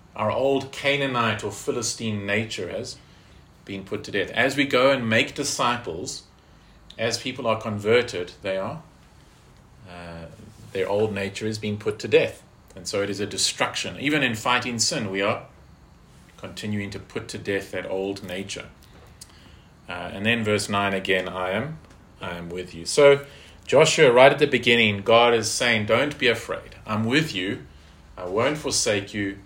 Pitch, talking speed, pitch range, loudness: 110 Hz, 170 wpm, 95-120 Hz, -23 LUFS